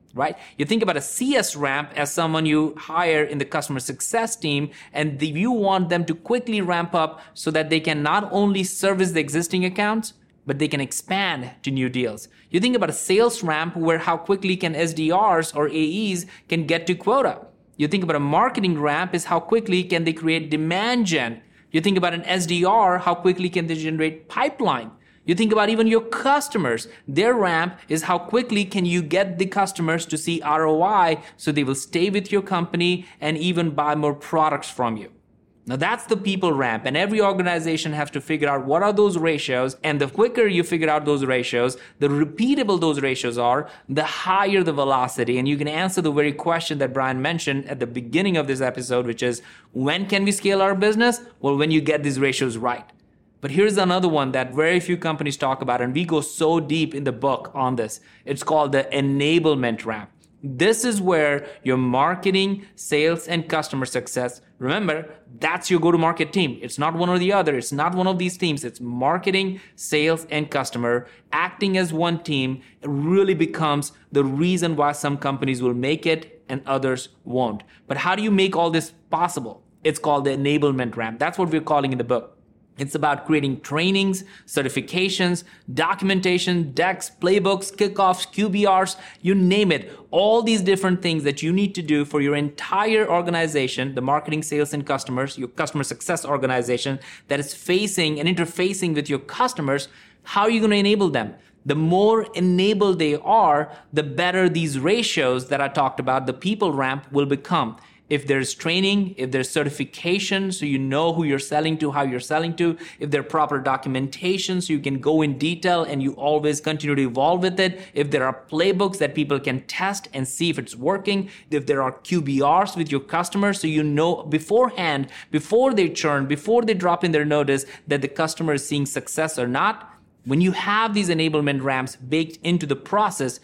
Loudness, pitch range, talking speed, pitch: -22 LUFS, 140-185 Hz, 195 wpm, 160 Hz